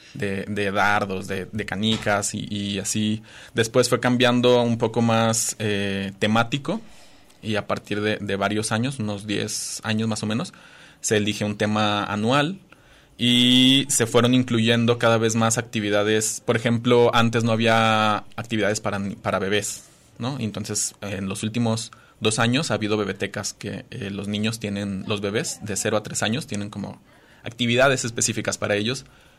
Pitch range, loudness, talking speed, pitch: 105-115 Hz, -22 LUFS, 165 wpm, 110 Hz